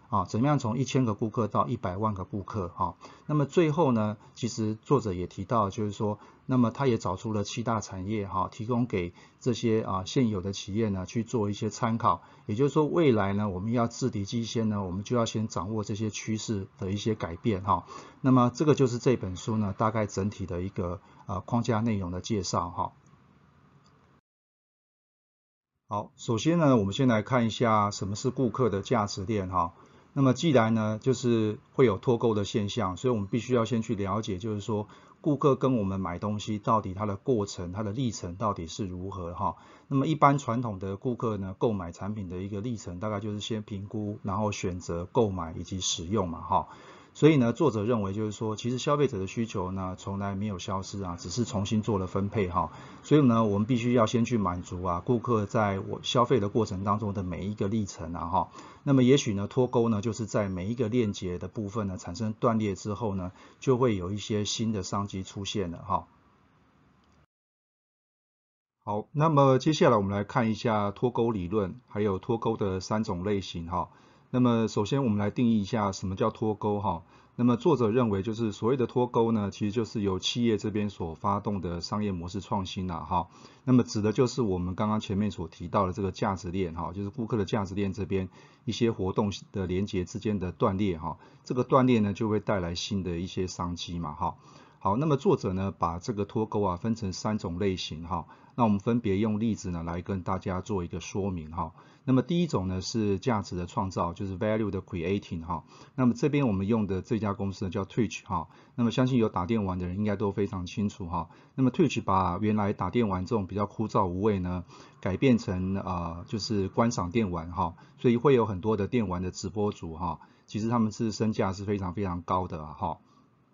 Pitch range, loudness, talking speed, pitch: 95-120 Hz, -29 LUFS, 320 characters per minute, 105 Hz